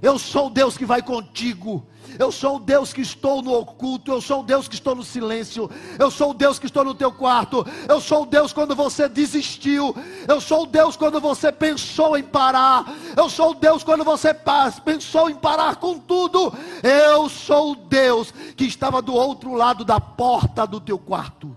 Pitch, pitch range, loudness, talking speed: 275 Hz, 250-305 Hz, -19 LUFS, 205 wpm